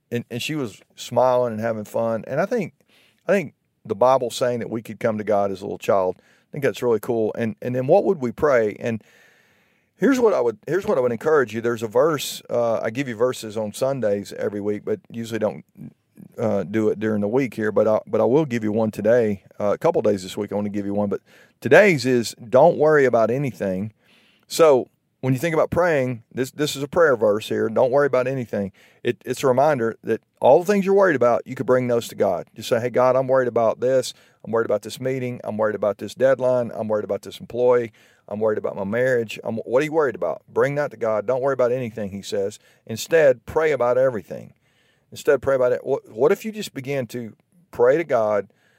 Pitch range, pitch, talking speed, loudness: 110-135 Hz, 120 Hz, 240 wpm, -21 LUFS